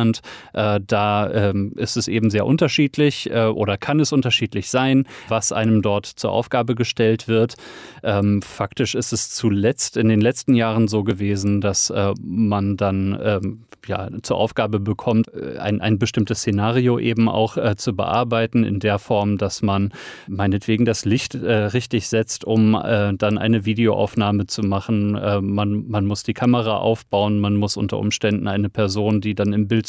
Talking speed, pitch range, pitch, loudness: 170 wpm, 100-115 Hz, 110 Hz, -20 LUFS